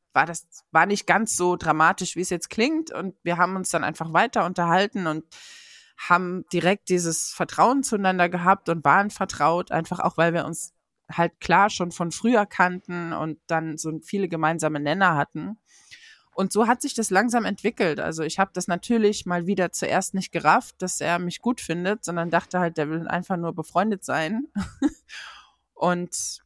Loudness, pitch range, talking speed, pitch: -23 LUFS, 165-205 Hz, 180 wpm, 180 Hz